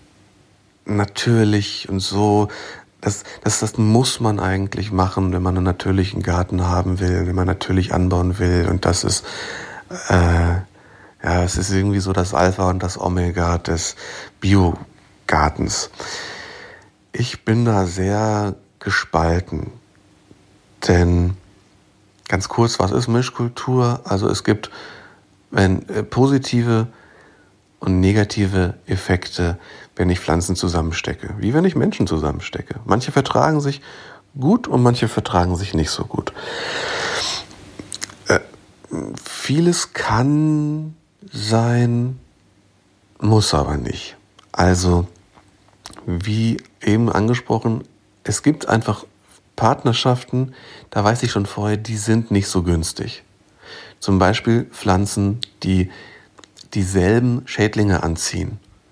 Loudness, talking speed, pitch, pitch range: -19 LUFS, 110 wpm, 100 Hz, 90-115 Hz